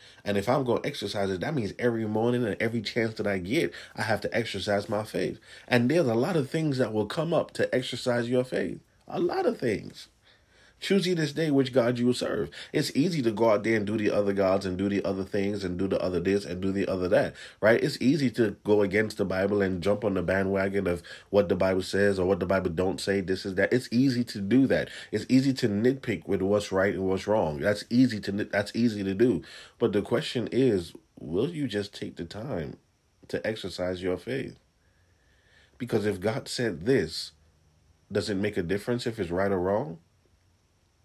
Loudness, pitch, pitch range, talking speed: -27 LUFS, 100 Hz, 95-120 Hz, 225 wpm